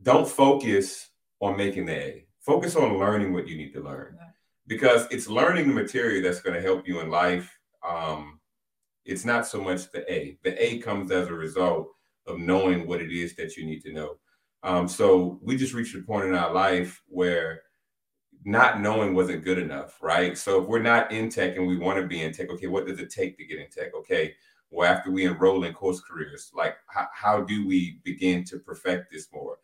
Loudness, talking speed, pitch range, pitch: -26 LUFS, 215 wpm, 90-115 Hz, 95 Hz